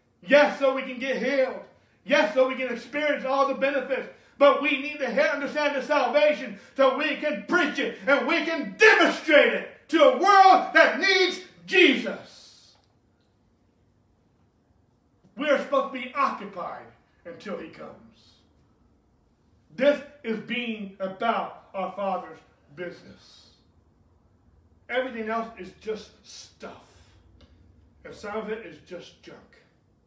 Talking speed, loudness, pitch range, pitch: 130 wpm, -23 LUFS, 185-290 Hz, 260 Hz